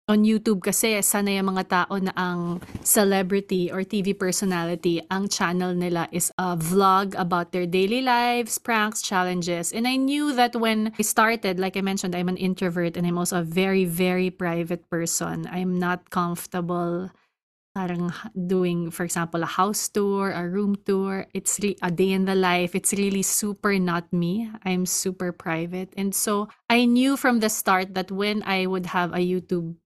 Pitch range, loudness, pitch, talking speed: 180-205 Hz, -24 LUFS, 185 Hz, 175 wpm